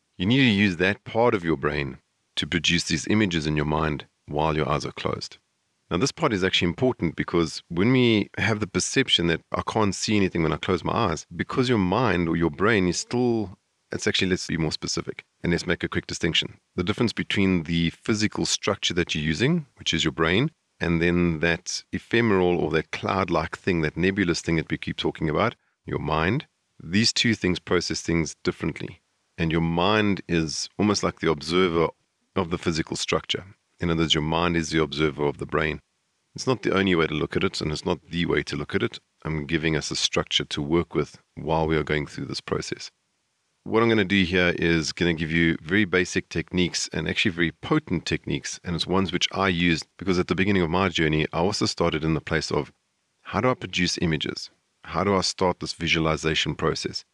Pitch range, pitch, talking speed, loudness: 80-100 Hz, 85 Hz, 220 wpm, -24 LUFS